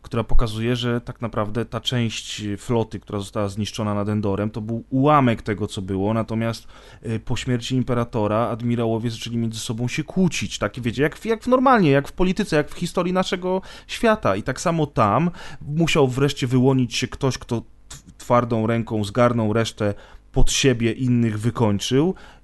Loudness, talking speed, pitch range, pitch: -22 LUFS, 165 wpm, 110-140 Hz, 120 Hz